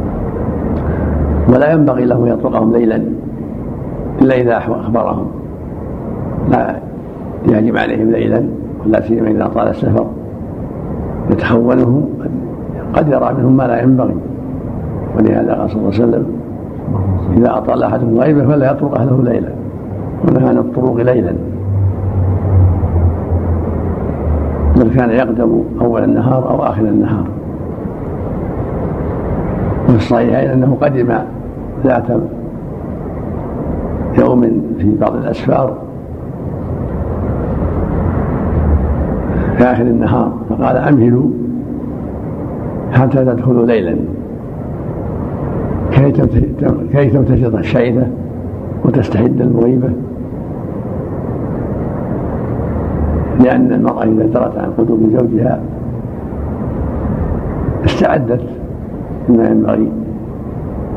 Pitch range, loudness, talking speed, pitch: 90-125 Hz, -14 LUFS, 80 wpm, 115 Hz